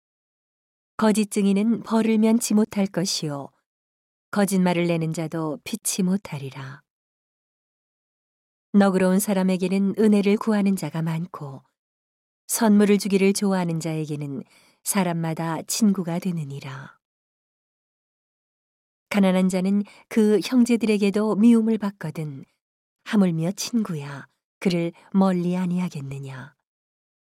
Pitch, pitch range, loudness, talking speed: 190 Hz, 160-205 Hz, -22 LUFS, 235 characters per minute